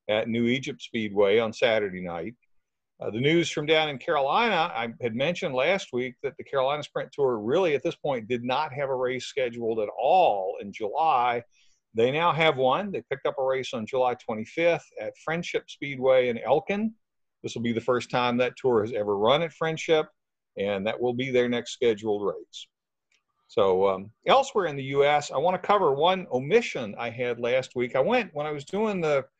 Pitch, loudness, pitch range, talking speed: 135 Hz, -26 LUFS, 120-180 Hz, 200 wpm